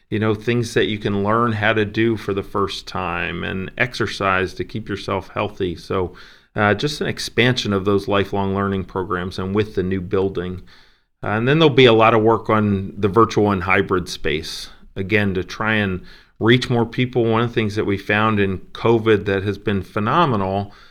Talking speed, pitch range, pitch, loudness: 200 wpm, 95-115 Hz, 105 Hz, -19 LUFS